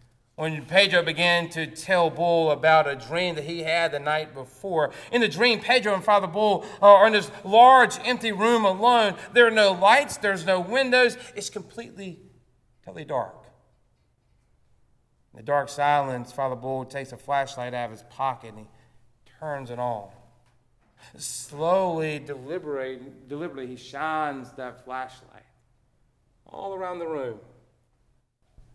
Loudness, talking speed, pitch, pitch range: -22 LUFS, 145 wpm, 150 Hz, 125-195 Hz